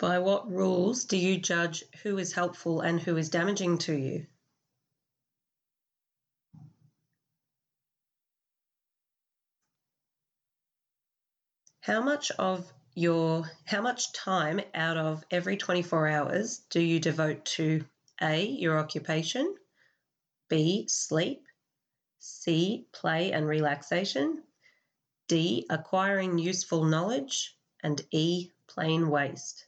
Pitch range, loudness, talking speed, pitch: 155-185 Hz, -29 LUFS, 95 wpm, 165 Hz